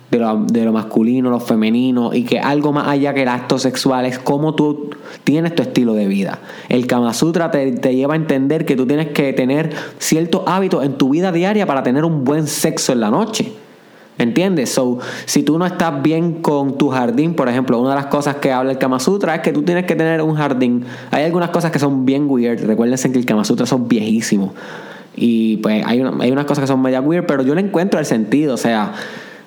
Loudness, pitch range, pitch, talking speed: -16 LUFS, 125-160 Hz, 140 Hz, 230 wpm